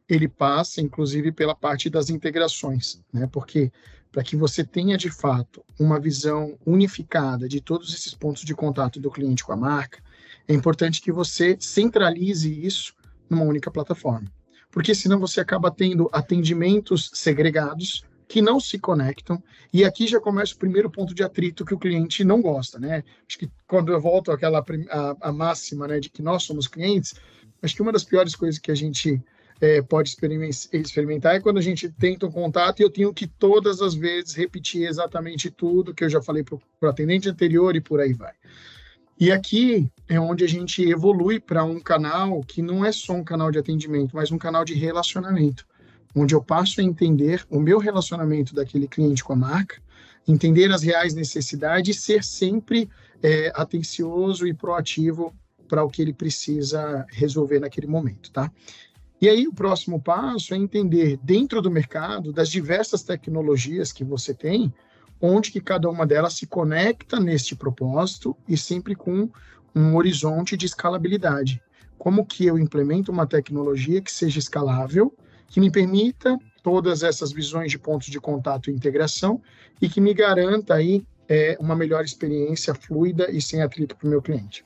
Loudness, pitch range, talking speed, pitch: -22 LUFS, 150-185 Hz, 175 wpm, 165 Hz